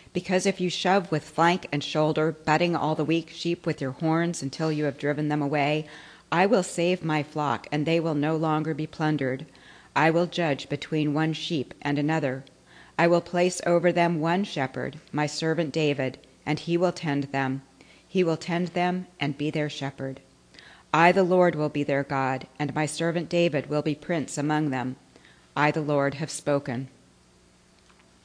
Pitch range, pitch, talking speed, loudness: 145-170 Hz, 155 Hz, 185 wpm, -26 LUFS